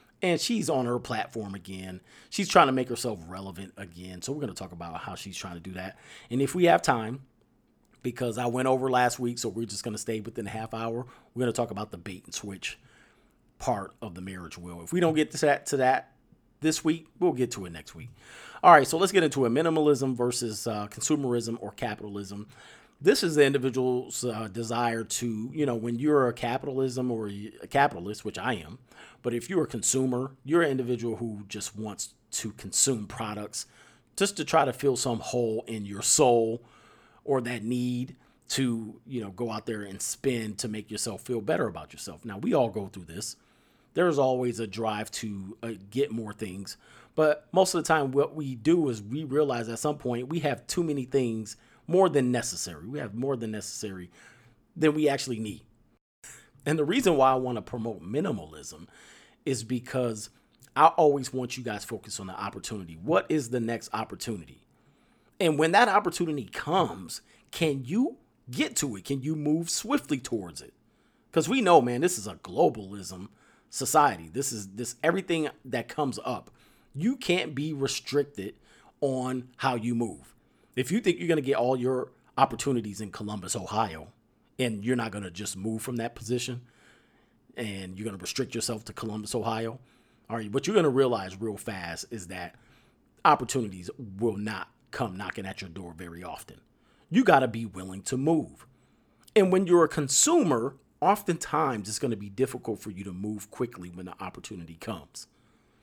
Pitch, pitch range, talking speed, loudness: 120 Hz, 105-135 Hz, 195 wpm, -28 LUFS